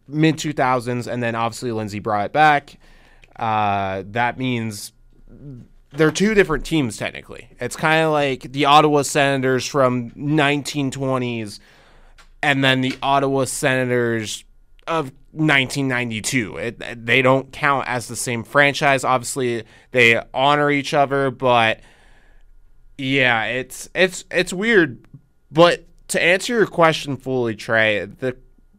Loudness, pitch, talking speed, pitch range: -19 LUFS, 130 Hz, 130 wpm, 115-145 Hz